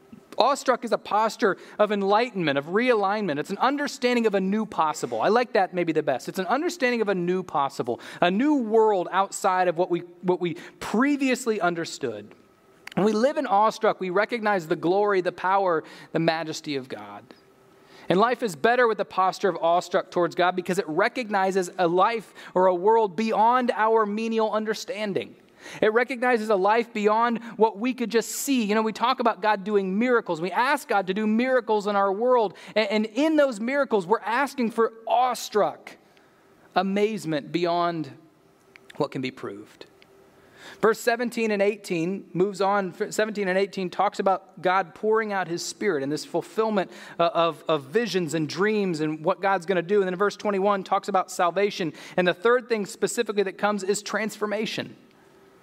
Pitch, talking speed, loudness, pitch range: 205 Hz, 180 wpm, -24 LUFS, 180-225 Hz